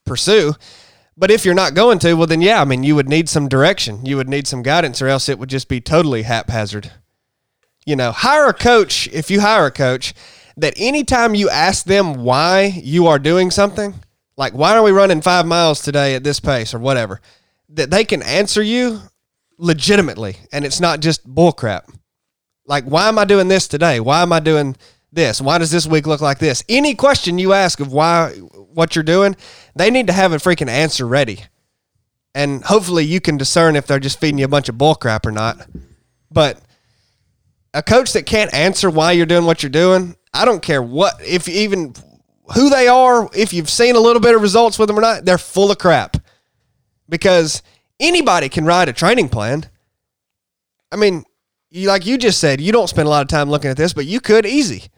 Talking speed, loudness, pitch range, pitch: 210 wpm, -14 LUFS, 135-195 Hz, 160 Hz